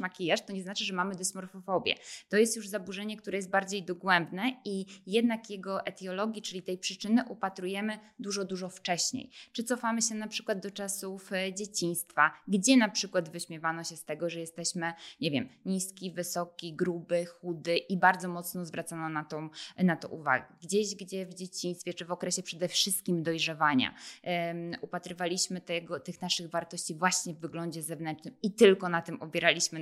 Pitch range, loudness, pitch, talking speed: 170-200 Hz, -32 LUFS, 185 Hz, 165 wpm